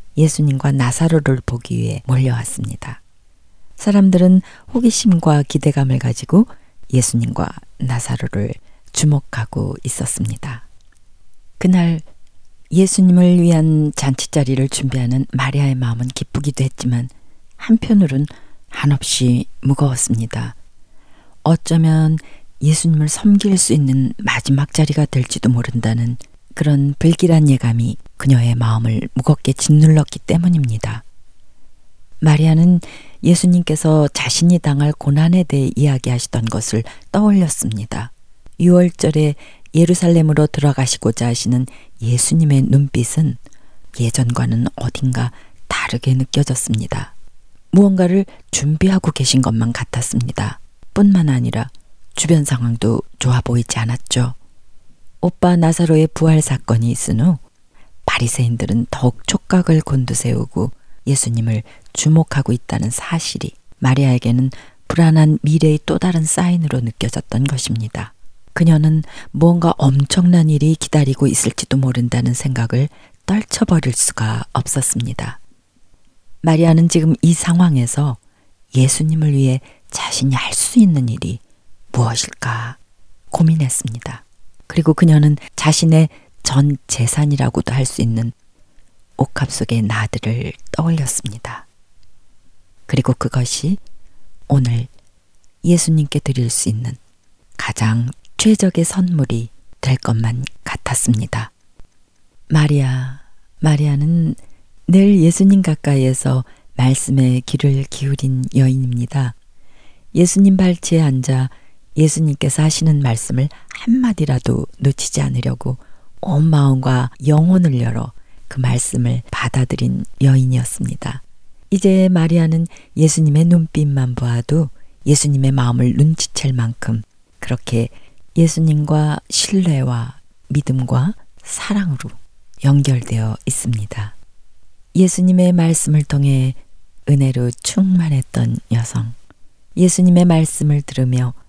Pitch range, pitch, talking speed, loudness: 115-155 Hz, 130 Hz, 265 characters per minute, -15 LUFS